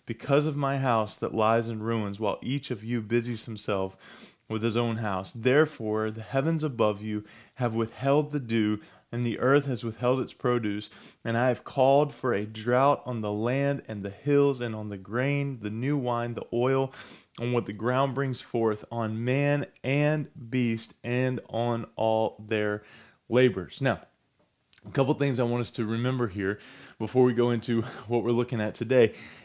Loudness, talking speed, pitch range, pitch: -28 LUFS, 185 wpm, 110-130 Hz, 120 Hz